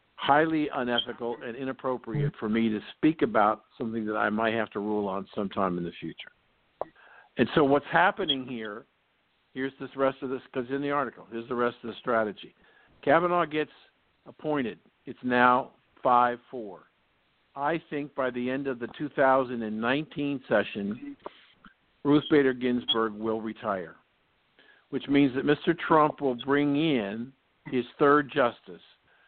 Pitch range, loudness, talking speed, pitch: 115-145 Hz, -27 LUFS, 150 wpm, 130 Hz